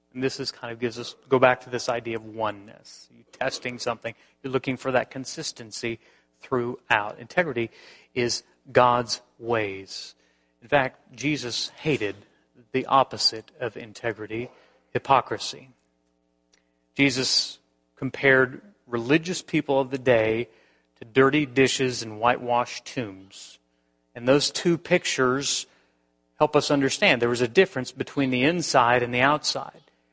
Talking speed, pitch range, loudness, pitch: 130 wpm, 110-135 Hz, -24 LUFS, 120 Hz